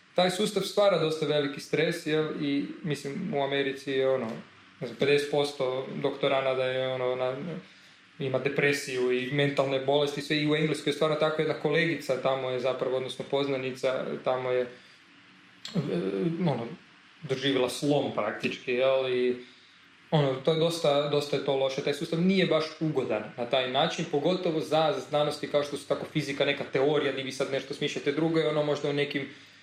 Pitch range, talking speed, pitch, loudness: 135-155 Hz, 170 wpm, 145 Hz, -28 LUFS